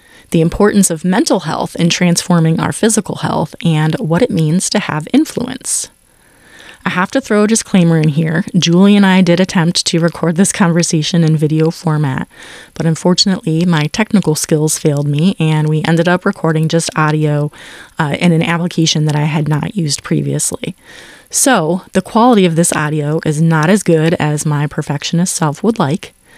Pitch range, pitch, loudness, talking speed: 155-185 Hz, 165 Hz, -13 LUFS, 175 wpm